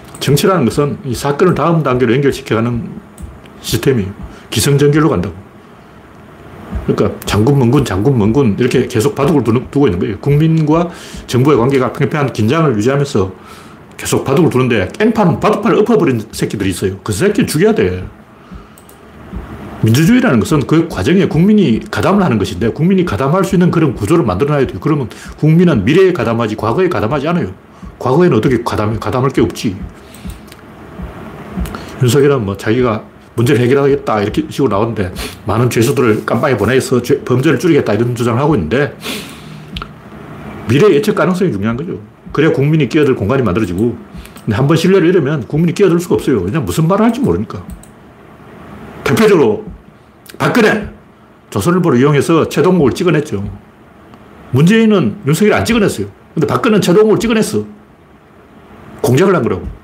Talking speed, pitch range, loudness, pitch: 375 characters per minute, 115-170 Hz, -13 LUFS, 140 Hz